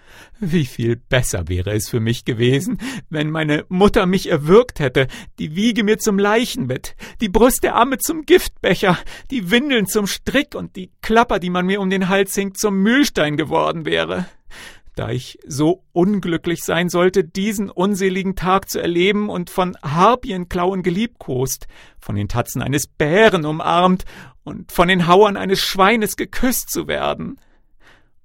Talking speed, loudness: 155 wpm, -18 LUFS